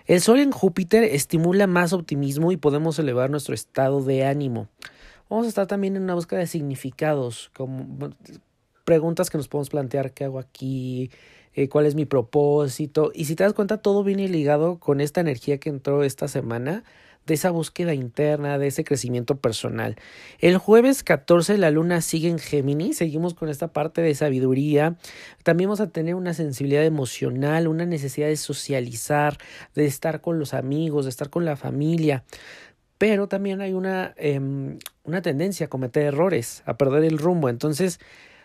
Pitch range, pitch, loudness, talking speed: 140-175 Hz, 155 Hz, -23 LUFS, 170 wpm